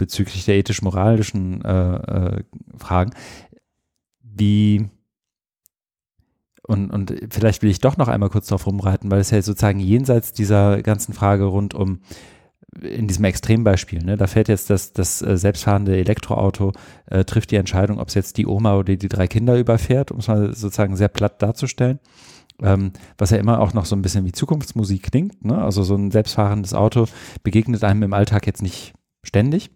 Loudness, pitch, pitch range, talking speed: -19 LUFS, 105 Hz, 100-110 Hz, 170 wpm